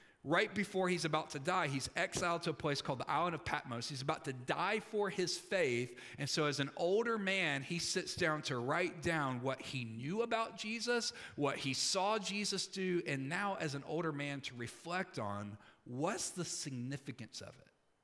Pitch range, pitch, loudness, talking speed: 135-185 Hz, 160 Hz, -37 LUFS, 195 wpm